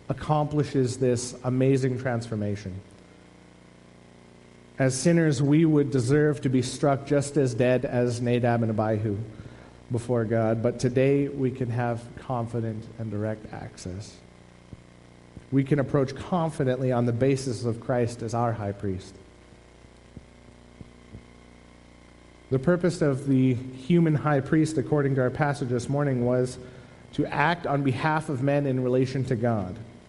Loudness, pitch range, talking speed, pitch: -25 LUFS, 100-135 Hz, 135 wpm, 125 Hz